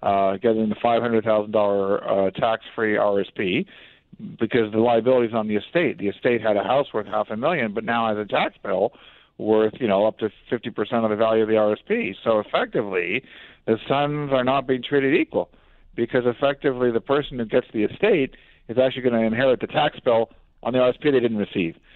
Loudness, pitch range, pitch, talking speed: -22 LUFS, 105-125 Hz, 115 Hz, 195 wpm